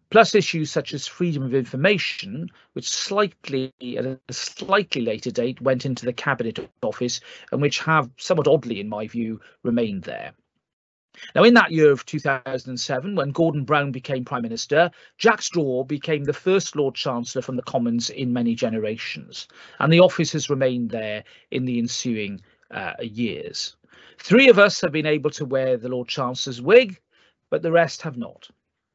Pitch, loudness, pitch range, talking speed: 135 Hz, -22 LUFS, 125-165 Hz, 170 wpm